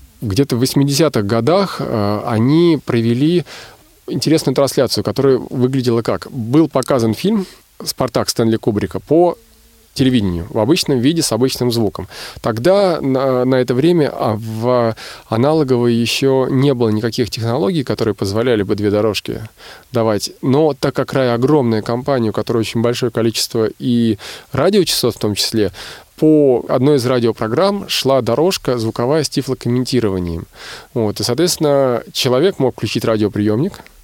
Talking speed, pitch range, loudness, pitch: 135 wpm, 110-140 Hz, -16 LUFS, 125 Hz